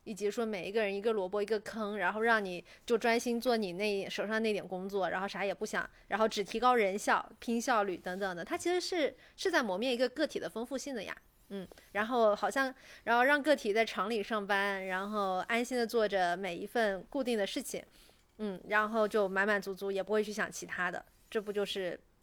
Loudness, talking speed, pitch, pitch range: -33 LUFS, 315 characters per minute, 215 Hz, 195-235 Hz